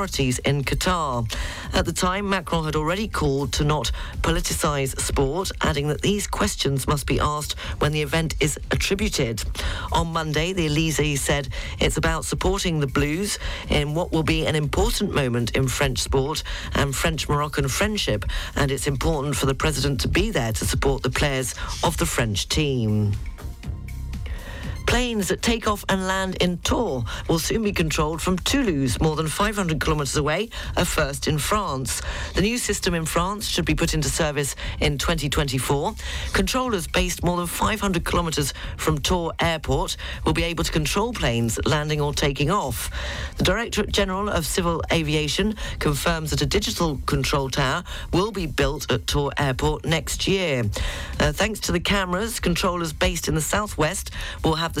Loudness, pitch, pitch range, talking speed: -23 LUFS, 150 Hz, 135-180 Hz, 170 wpm